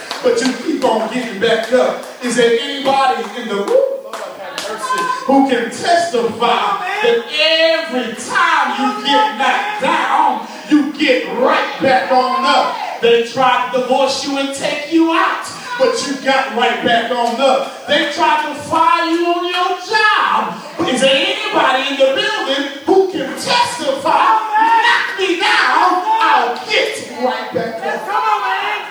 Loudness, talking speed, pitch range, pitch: -14 LUFS, 150 wpm, 255-360 Hz, 275 Hz